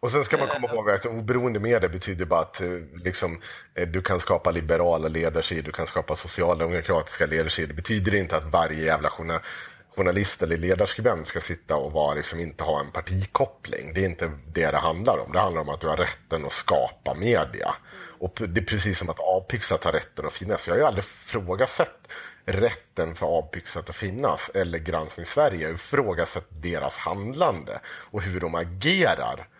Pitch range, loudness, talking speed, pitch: 80-95 Hz, -26 LUFS, 180 wpm, 90 Hz